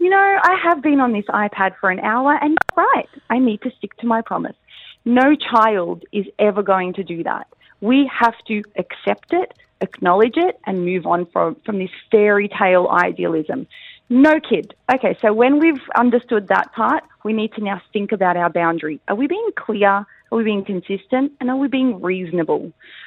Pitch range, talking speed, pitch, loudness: 195-275 Hz, 195 wpm, 220 Hz, -18 LUFS